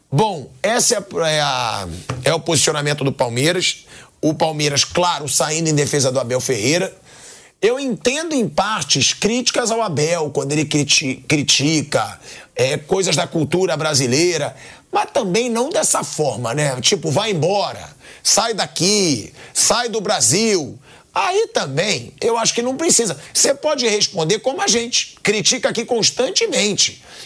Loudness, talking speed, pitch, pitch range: -17 LUFS, 145 wpm, 175 Hz, 145-235 Hz